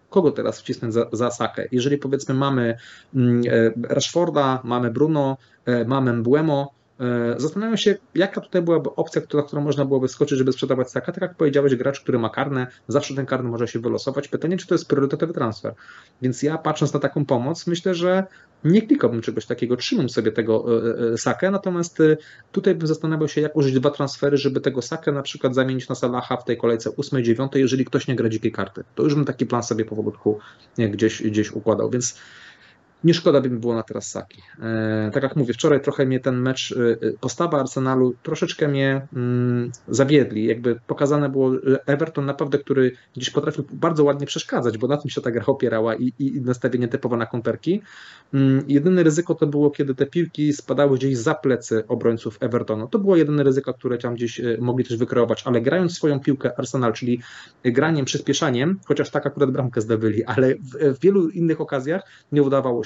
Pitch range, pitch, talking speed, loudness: 120-150 Hz, 135 Hz, 180 wpm, -21 LUFS